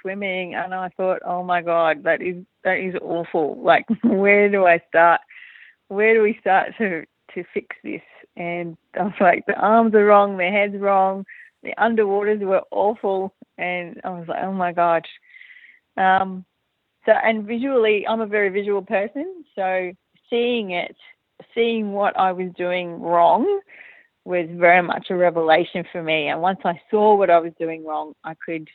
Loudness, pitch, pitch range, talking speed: -20 LUFS, 190 Hz, 175-215 Hz, 175 wpm